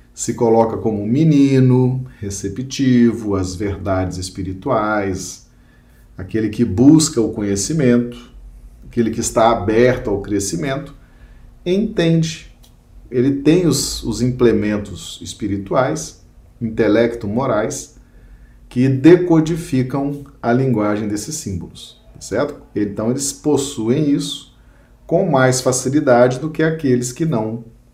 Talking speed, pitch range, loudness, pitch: 105 wpm, 105-140 Hz, -17 LUFS, 120 Hz